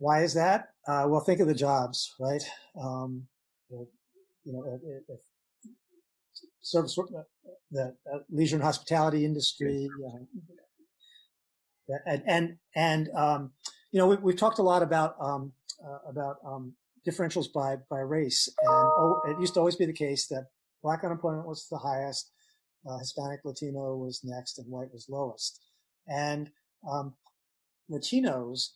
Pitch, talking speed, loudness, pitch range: 150 Hz, 150 wpm, -30 LUFS, 135-175 Hz